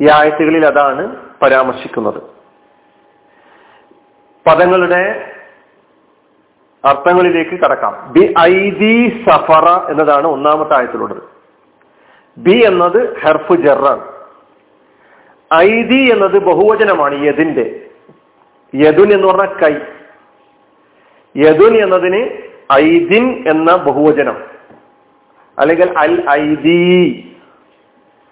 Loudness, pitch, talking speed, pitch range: -10 LUFS, 180 Hz, 70 wpm, 155-220 Hz